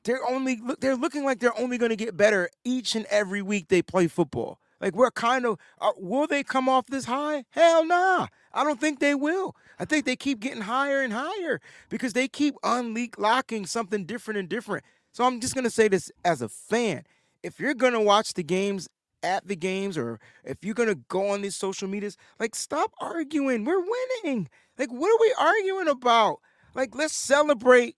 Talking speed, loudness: 200 wpm, -25 LUFS